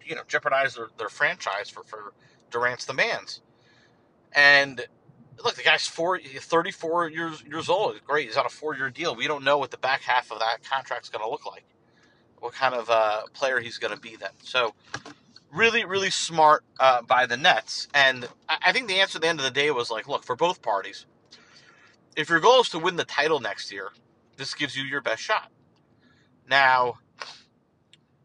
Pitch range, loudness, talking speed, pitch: 125-165 Hz, -24 LUFS, 195 wpm, 140 Hz